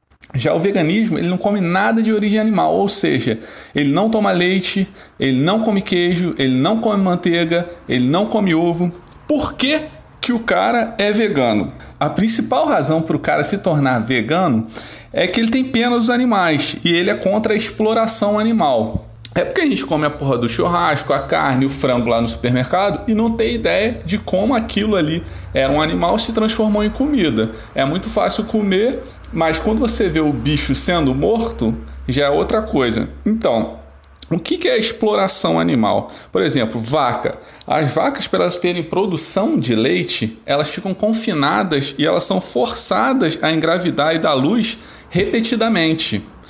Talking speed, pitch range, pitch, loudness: 175 wpm, 145-220 Hz, 185 Hz, -16 LUFS